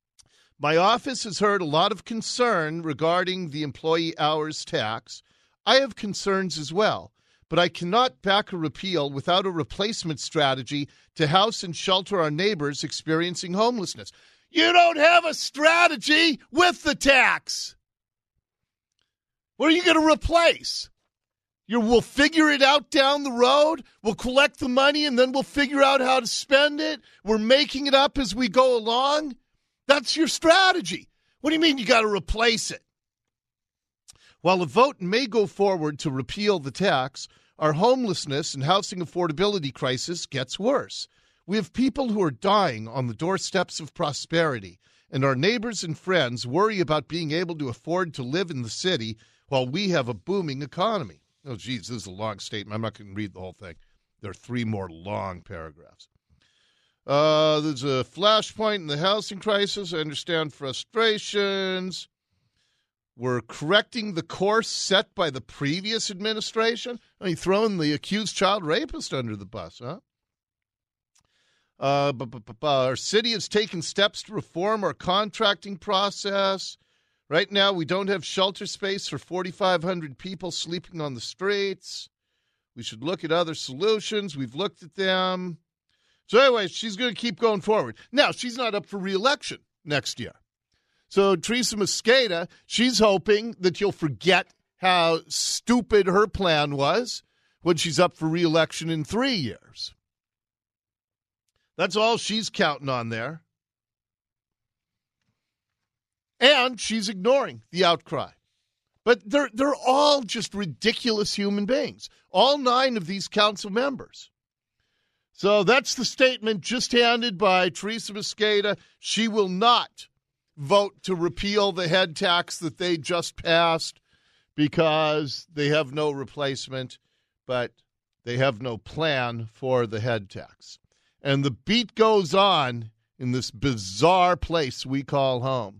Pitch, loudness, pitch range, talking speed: 180 Hz, -23 LUFS, 140-220 Hz, 150 wpm